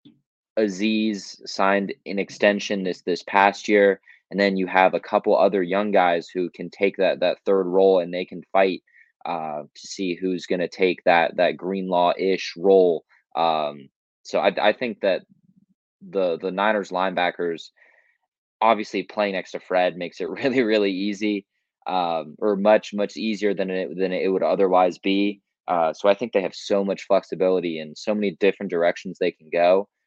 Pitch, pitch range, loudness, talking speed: 95 Hz, 90-105 Hz, -22 LUFS, 180 wpm